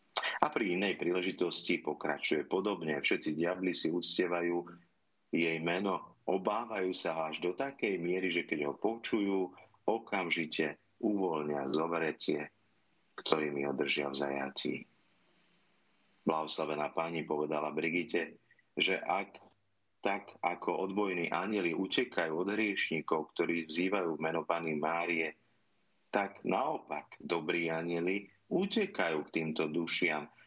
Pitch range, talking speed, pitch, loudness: 80-95 Hz, 110 wpm, 85 Hz, -34 LUFS